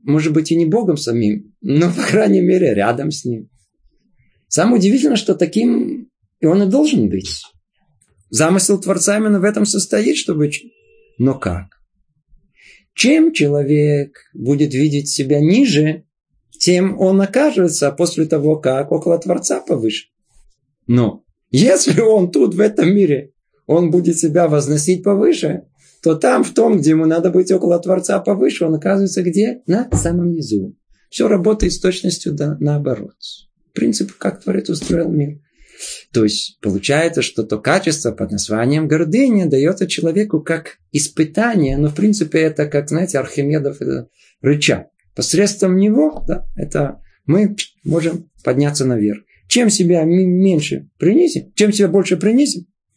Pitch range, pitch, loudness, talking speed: 145-195 Hz, 165 Hz, -15 LUFS, 140 wpm